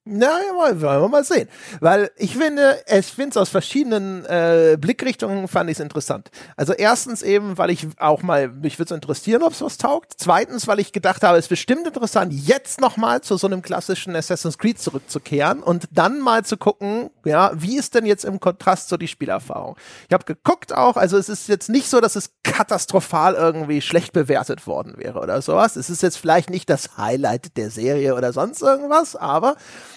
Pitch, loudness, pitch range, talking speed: 195 Hz, -19 LUFS, 165-230 Hz, 200 wpm